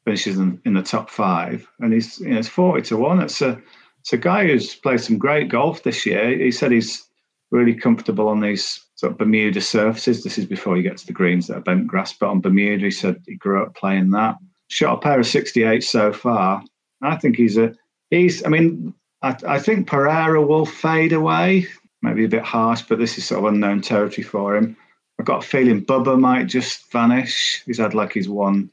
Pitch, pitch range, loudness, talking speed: 115 Hz, 105-155 Hz, -19 LUFS, 215 wpm